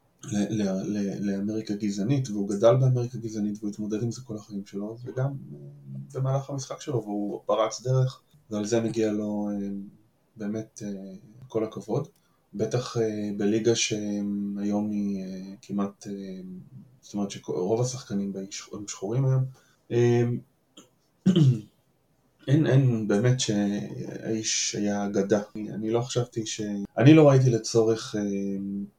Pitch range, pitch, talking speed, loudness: 100-120 Hz, 110 Hz, 140 wpm, -27 LUFS